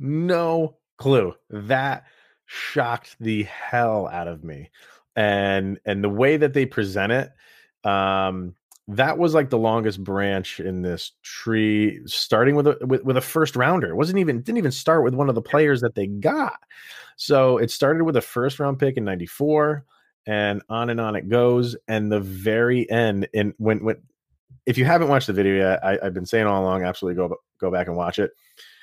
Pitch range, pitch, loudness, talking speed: 100-135 Hz, 115 Hz, -22 LUFS, 190 wpm